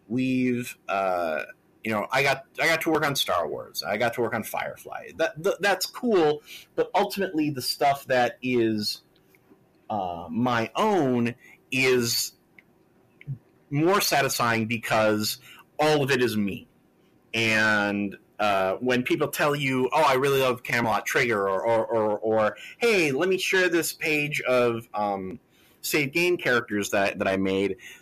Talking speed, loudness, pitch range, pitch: 155 wpm, -25 LUFS, 110-150 Hz, 125 Hz